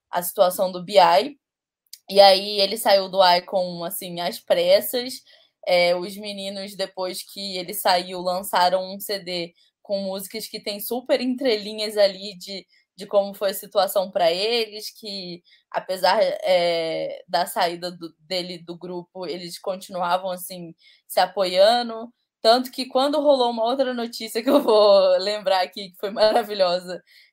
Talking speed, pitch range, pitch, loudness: 150 wpm, 180-225 Hz, 195 Hz, -22 LUFS